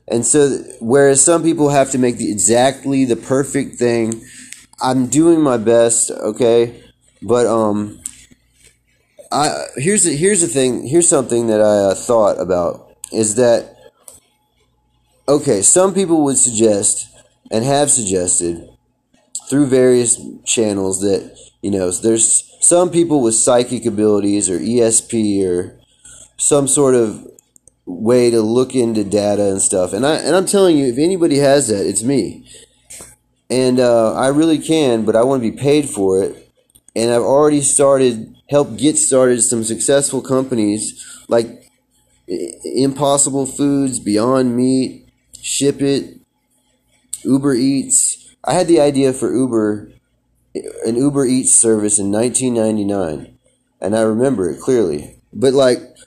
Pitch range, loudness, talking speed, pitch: 110-140 Hz, -14 LUFS, 140 wpm, 125 Hz